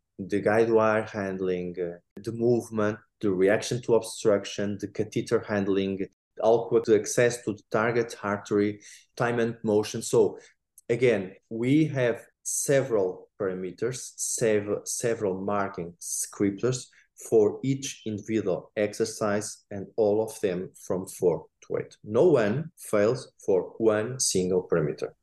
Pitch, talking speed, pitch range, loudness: 110 Hz, 125 wpm, 100-120 Hz, -27 LUFS